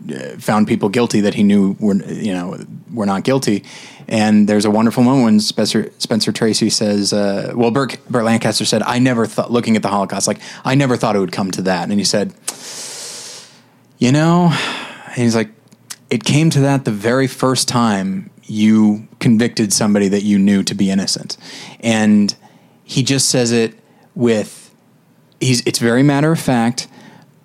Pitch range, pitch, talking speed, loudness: 105-135 Hz, 115 Hz, 175 wpm, -15 LUFS